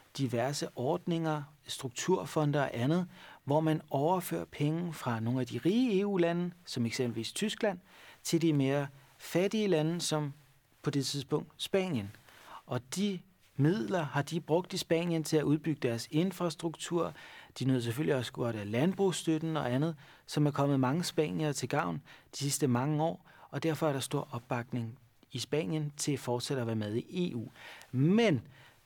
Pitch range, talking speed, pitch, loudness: 130-170 Hz, 160 wpm, 150 Hz, -33 LUFS